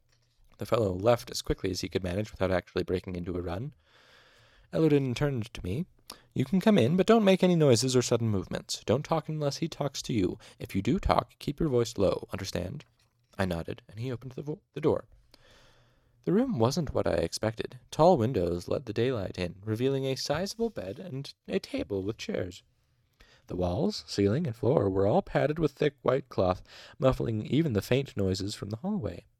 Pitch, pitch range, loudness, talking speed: 115 Hz, 95-135 Hz, -29 LUFS, 200 wpm